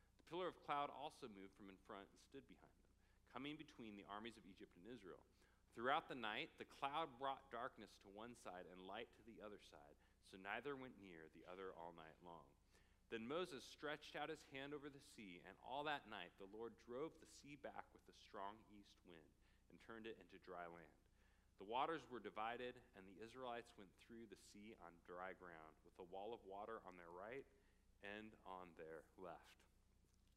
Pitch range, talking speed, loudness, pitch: 90-115 Hz, 200 wpm, -54 LUFS, 100 Hz